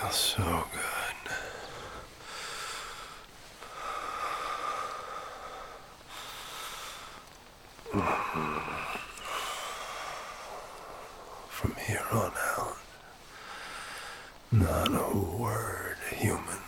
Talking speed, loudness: 45 wpm, -34 LUFS